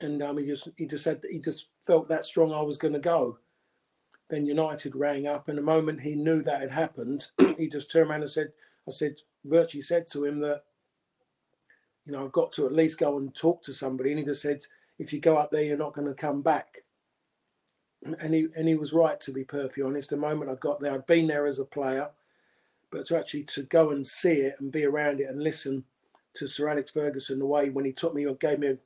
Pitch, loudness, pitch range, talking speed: 145 Hz, -28 LUFS, 140-160 Hz, 240 wpm